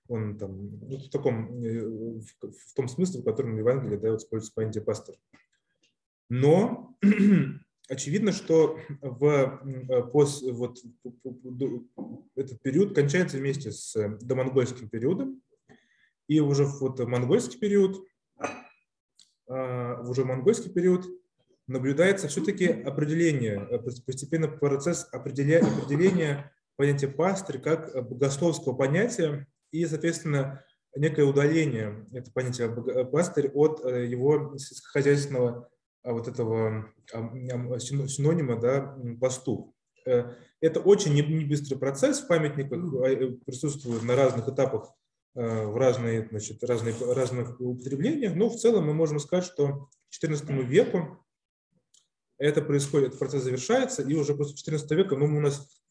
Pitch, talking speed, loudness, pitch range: 135 Hz, 115 wpm, -27 LUFS, 125-155 Hz